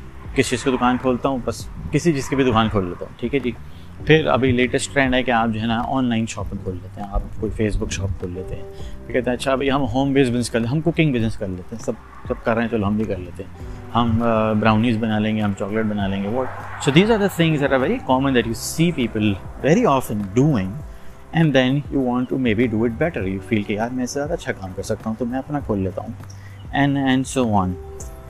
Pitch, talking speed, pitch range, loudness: 115 Hz, 250 wpm, 100-130 Hz, -21 LUFS